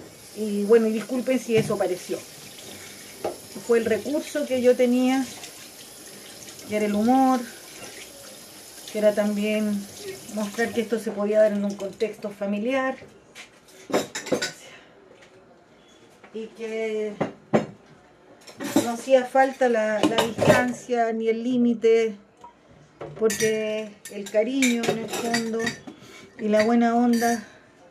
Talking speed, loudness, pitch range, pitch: 110 wpm, -24 LUFS, 215-245 Hz, 225 Hz